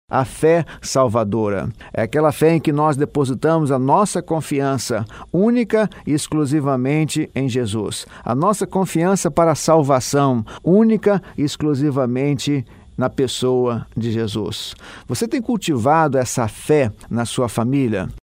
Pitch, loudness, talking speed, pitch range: 140 Hz, -18 LUFS, 130 wpm, 125-160 Hz